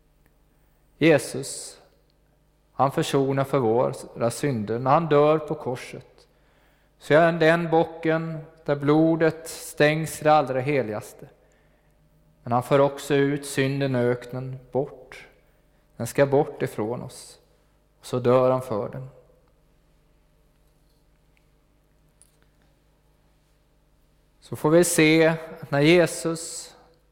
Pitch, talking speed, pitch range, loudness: 150 Hz, 115 wpm, 135-160 Hz, -23 LUFS